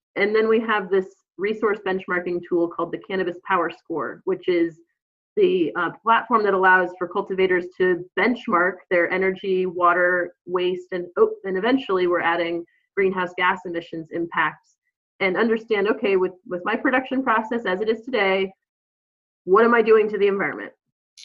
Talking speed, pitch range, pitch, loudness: 160 wpm, 180-225 Hz, 190 Hz, -22 LUFS